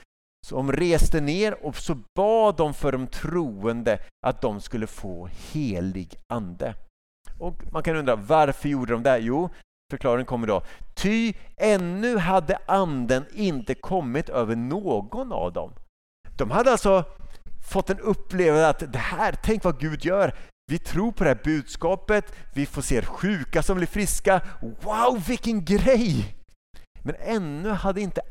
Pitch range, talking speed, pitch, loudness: 135-200 Hz, 155 wpm, 170 Hz, -25 LUFS